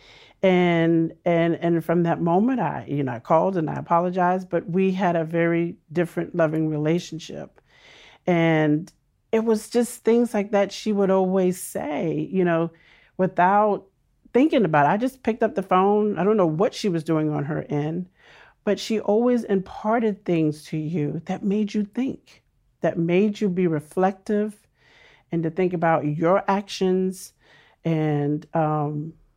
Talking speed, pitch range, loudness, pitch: 160 wpm, 165-205 Hz, -23 LUFS, 180 Hz